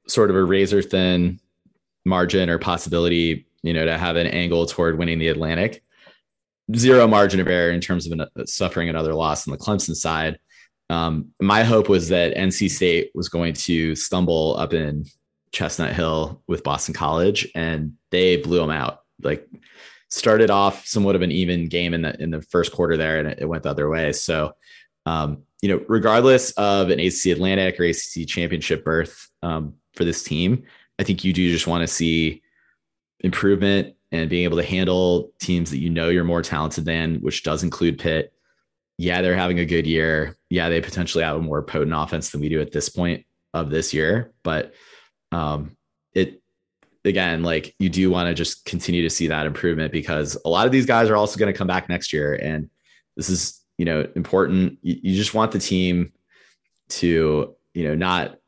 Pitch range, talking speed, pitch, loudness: 80-90 Hz, 195 wpm, 85 Hz, -21 LUFS